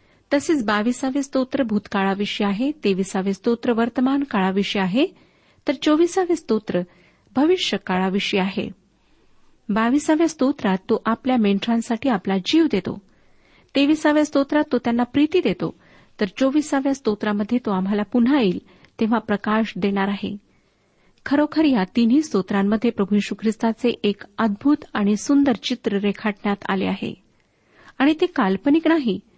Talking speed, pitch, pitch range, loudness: 110 wpm, 230 Hz, 205-280 Hz, -21 LUFS